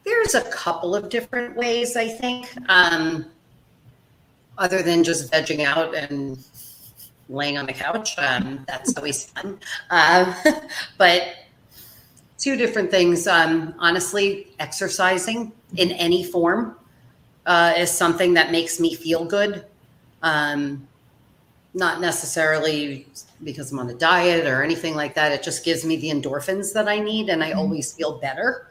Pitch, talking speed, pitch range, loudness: 165 Hz, 140 wpm, 145-190 Hz, -21 LUFS